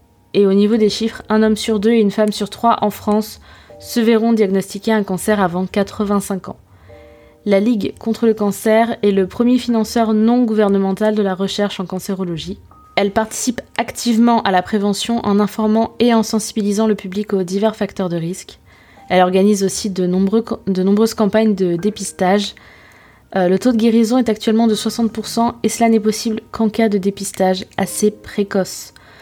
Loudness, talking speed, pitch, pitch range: -16 LUFS, 180 wpm, 210 Hz, 195-225 Hz